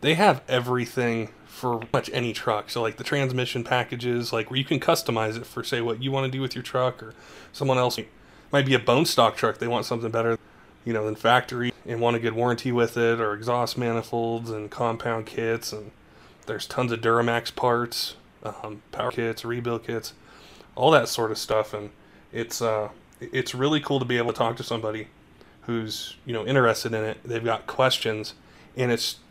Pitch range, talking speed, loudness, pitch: 115-125 Hz, 205 wpm, -25 LUFS, 115 Hz